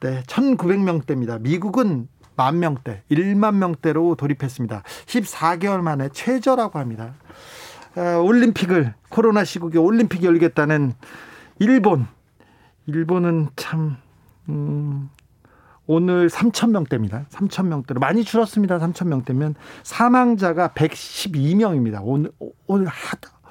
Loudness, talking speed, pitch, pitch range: -20 LUFS, 245 characters per minute, 165 Hz, 140-195 Hz